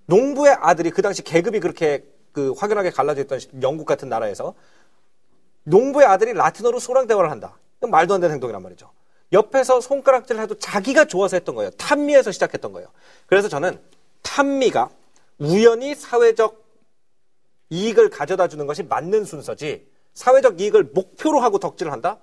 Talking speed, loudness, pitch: 375 characters per minute, -19 LUFS, 265 Hz